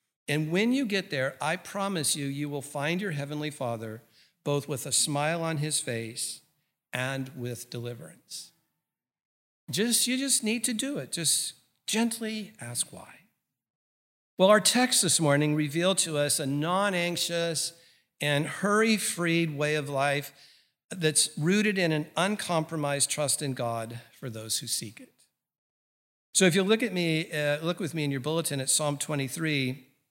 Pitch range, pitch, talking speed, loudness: 140-175 Hz, 150 Hz, 160 wpm, -27 LUFS